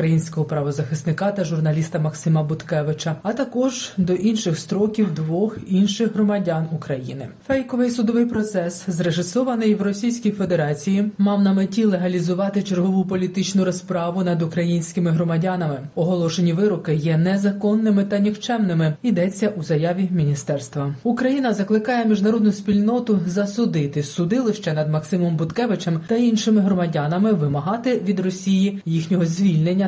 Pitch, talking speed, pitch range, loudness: 185 Hz, 120 wpm, 165-210 Hz, -21 LUFS